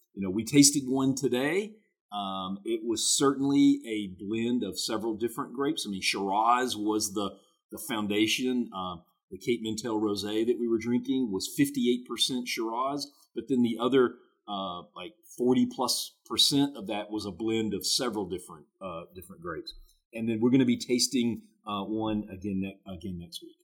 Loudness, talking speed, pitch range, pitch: -28 LUFS, 175 wpm, 105-130 Hz, 115 Hz